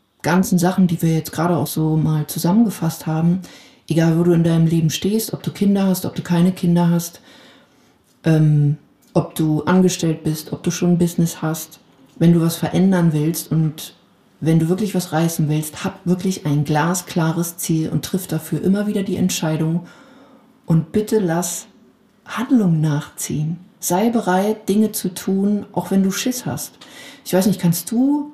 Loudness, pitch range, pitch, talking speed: -19 LUFS, 160-195 Hz, 175 Hz, 175 wpm